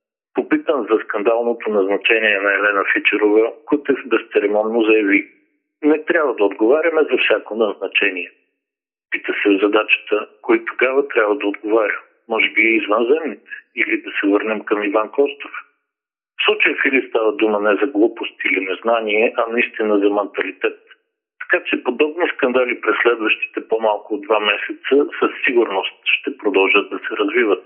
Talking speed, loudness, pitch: 150 wpm, -17 LUFS, 150 Hz